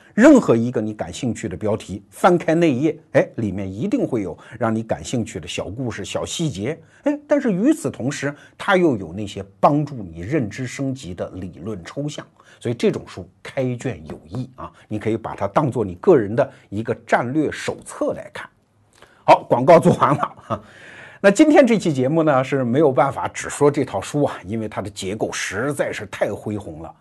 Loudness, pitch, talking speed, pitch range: -20 LUFS, 130 Hz, 280 characters per minute, 105-160 Hz